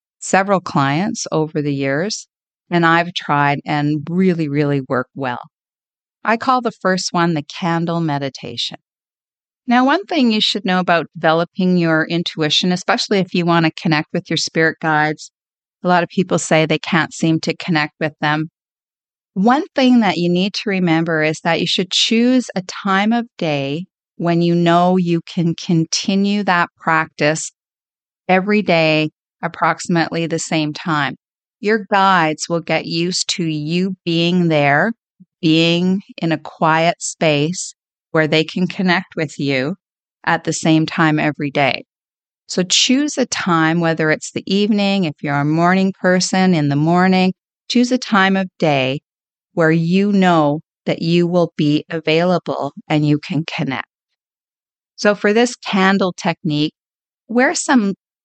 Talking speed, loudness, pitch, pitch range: 155 wpm, -17 LUFS, 170 Hz, 155-190 Hz